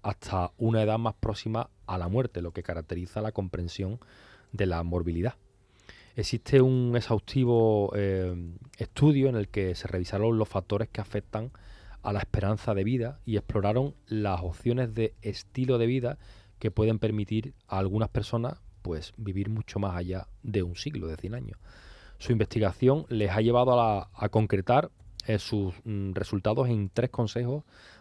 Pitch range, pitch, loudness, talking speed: 95-115 Hz, 105 Hz, -29 LUFS, 165 wpm